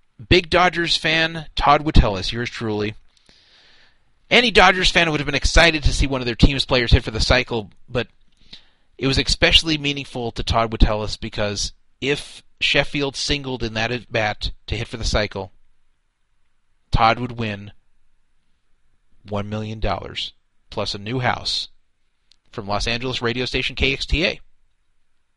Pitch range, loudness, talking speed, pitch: 100-135 Hz, -20 LUFS, 145 wpm, 115 Hz